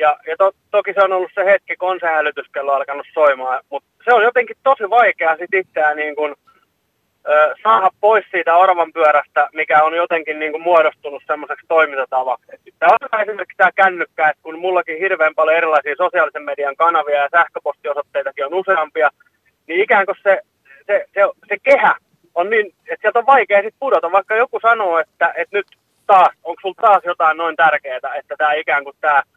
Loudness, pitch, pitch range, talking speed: -16 LUFS, 170 Hz, 150-205 Hz, 185 wpm